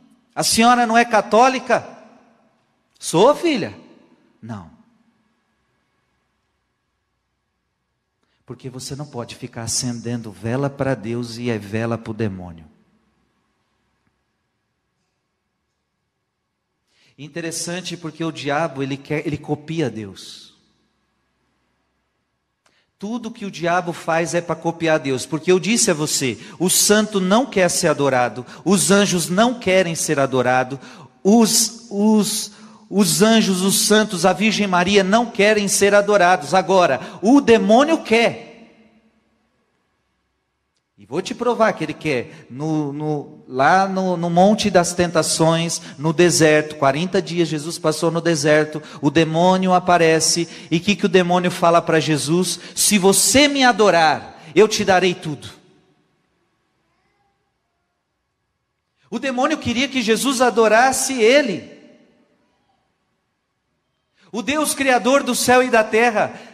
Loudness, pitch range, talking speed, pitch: -17 LUFS, 155-220 Hz, 120 wpm, 180 Hz